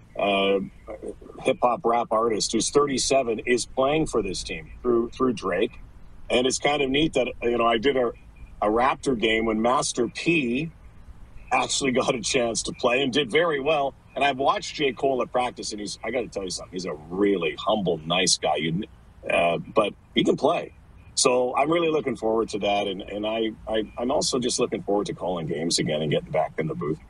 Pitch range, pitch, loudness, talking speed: 110-135 Hz, 120 Hz, -24 LUFS, 210 wpm